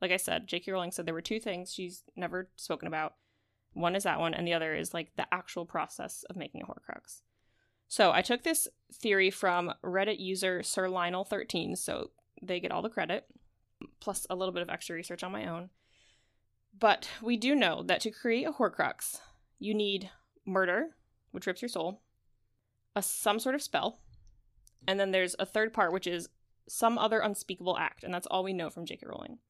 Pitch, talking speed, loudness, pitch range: 185 Hz, 195 wpm, -32 LUFS, 170-215 Hz